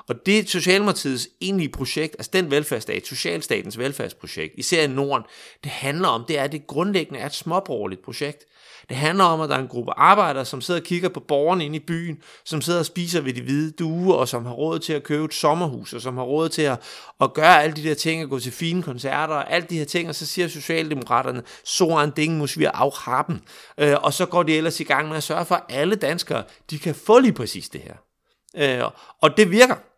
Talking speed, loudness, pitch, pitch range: 230 wpm, -22 LUFS, 155 Hz, 145-175 Hz